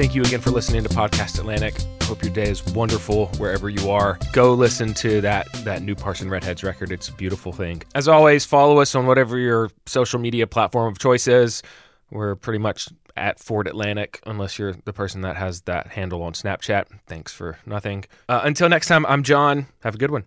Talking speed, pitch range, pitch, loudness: 210 wpm, 95-125 Hz, 105 Hz, -20 LUFS